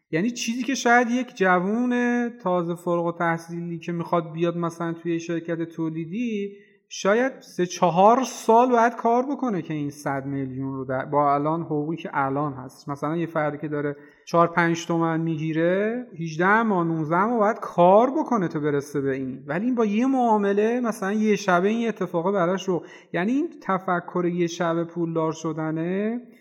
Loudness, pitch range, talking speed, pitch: -24 LUFS, 160-215 Hz, 170 wpm, 175 Hz